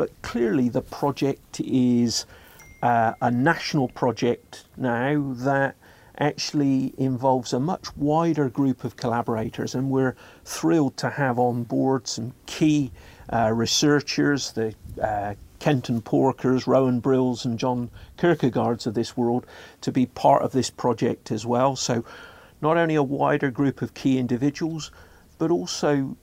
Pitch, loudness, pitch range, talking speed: 130 Hz, -24 LUFS, 120-140 Hz, 140 wpm